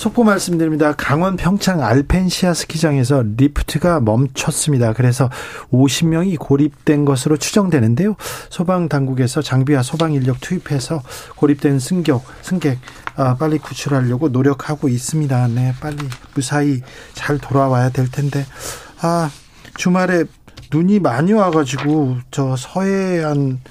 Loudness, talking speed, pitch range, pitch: -17 LUFS, 295 characters per minute, 130-165 Hz, 145 Hz